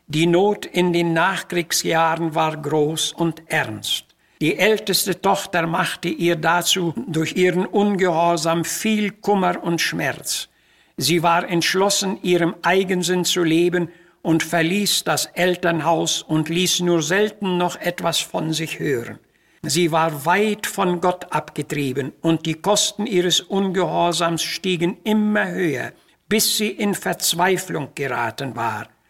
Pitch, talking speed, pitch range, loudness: 175 Hz, 130 wpm, 165-185 Hz, -20 LUFS